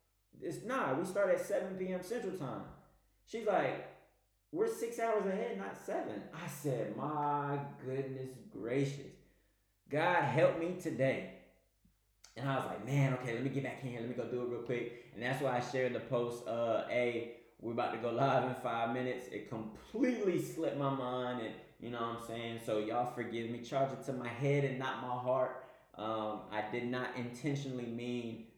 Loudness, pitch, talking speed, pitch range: -37 LUFS, 125 Hz, 195 wpm, 120-140 Hz